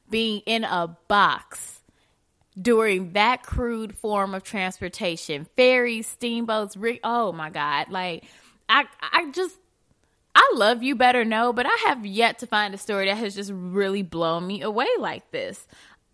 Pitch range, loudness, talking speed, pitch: 190-240 Hz, -23 LUFS, 155 wpm, 215 Hz